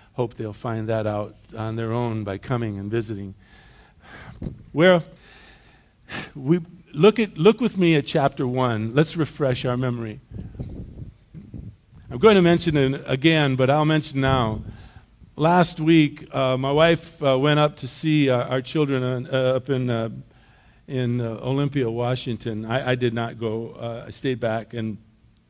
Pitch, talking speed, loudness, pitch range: 130 Hz, 160 wpm, -22 LUFS, 115-150 Hz